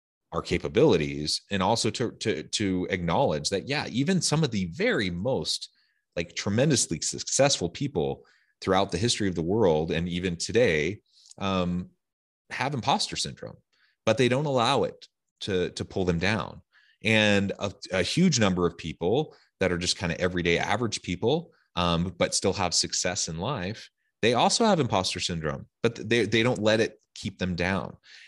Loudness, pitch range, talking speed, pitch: -26 LUFS, 90-115 Hz, 170 wpm, 95 Hz